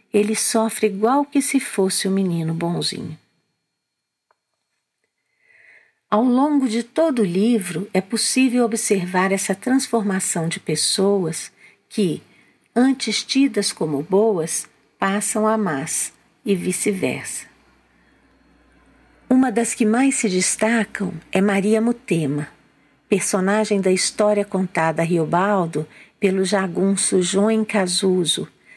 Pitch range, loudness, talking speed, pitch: 185-225 Hz, -20 LUFS, 110 wpm, 205 Hz